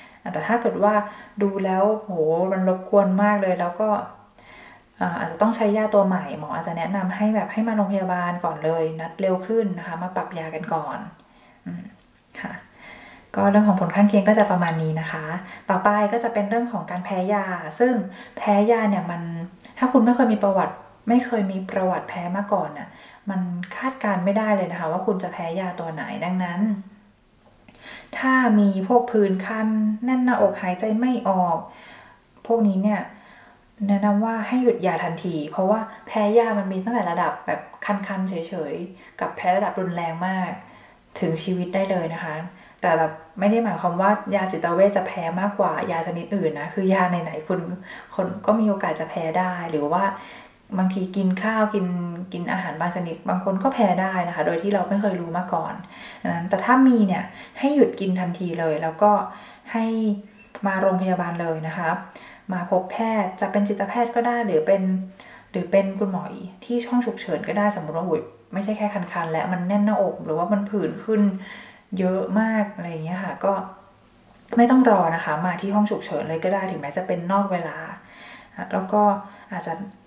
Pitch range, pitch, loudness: 175-210 Hz, 195 Hz, -23 LUFS